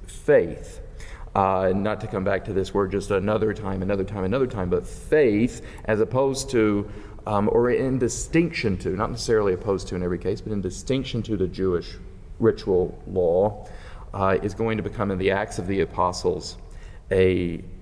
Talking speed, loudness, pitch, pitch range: 180 wpm, -24 LUFS, 100 Hz, 95-110 Hz